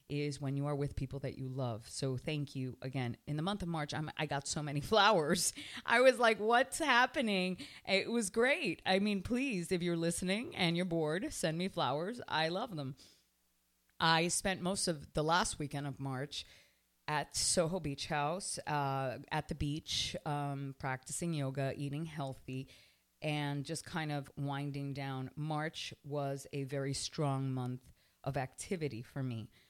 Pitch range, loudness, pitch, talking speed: 135-175 Hz, -36 LUFS, 145 Hz, 170 wpm